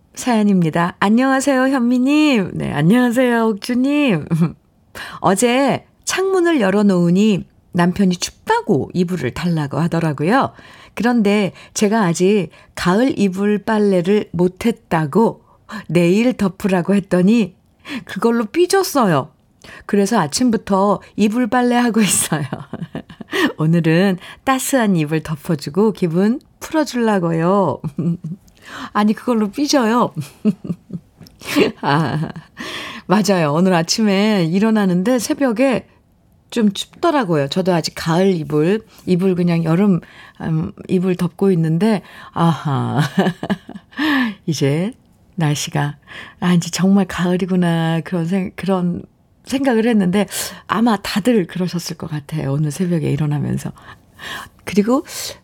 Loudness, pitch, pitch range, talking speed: -17 LUFS, 195 Hz, 170-230 Hz, 245 characters per minute